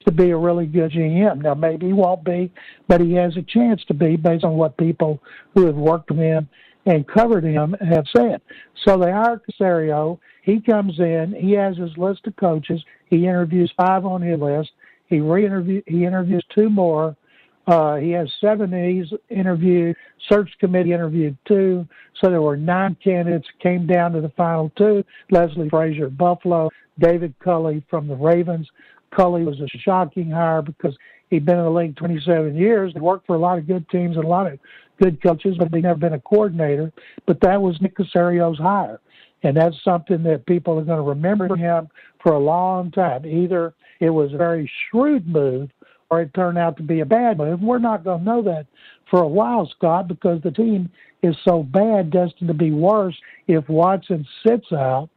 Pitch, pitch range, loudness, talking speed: 175 Hz, 165-190 Hz, -19 LUFS, 195 wpm